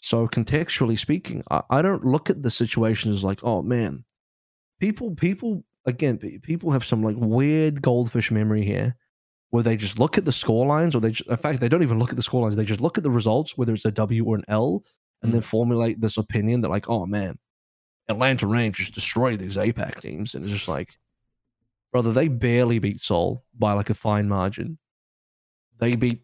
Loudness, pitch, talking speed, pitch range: -23 LUFS, 115 Hz, 205 wpm, 110-130 Hz